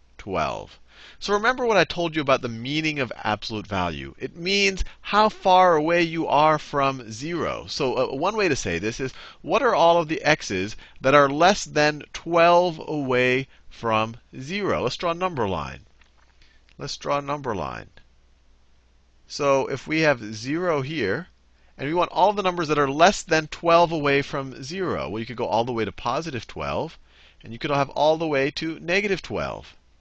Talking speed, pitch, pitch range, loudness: 190 wpm, 140 Hz, 110-170 Hz, -23 LUFS